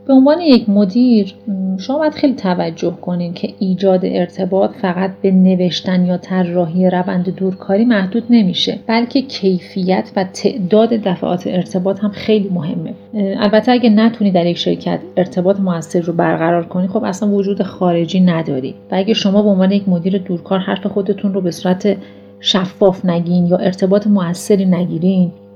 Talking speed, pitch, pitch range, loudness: 155 wpm, 190 Hz, 180-205 Hz, -15 LUFS